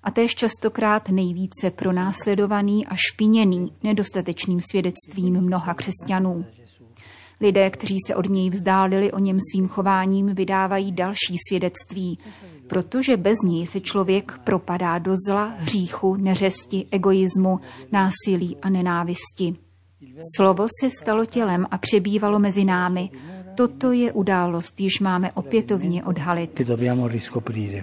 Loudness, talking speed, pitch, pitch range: -21 LUFS, 115 wpm, 190 Hz, 180-200 Hz